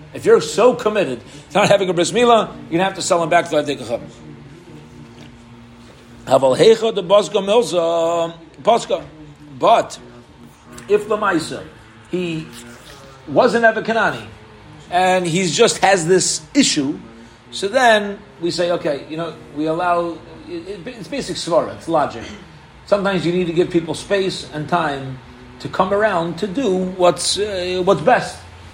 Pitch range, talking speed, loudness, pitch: 145-200 Hz, 140 wpm, -17 LUFS, 175 Hz